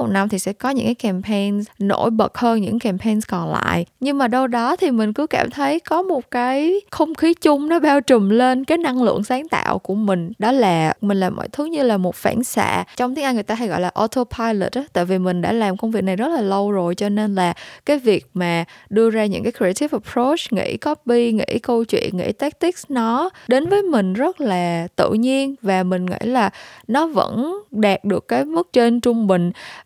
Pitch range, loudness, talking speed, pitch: 195-265 Hz, -19 LUFS, 230 wpm, 230 Hz